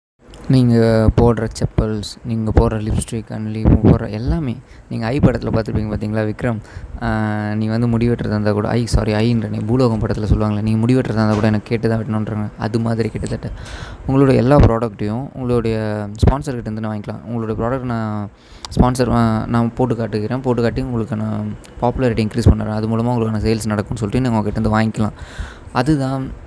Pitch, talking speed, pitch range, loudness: 110 Hz, 160 wpm, 110-120 Hz, -18 LUFS